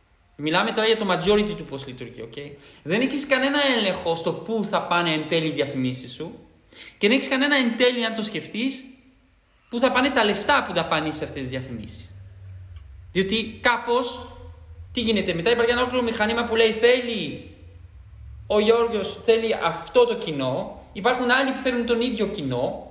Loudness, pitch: -22 LUFS, 210 Hz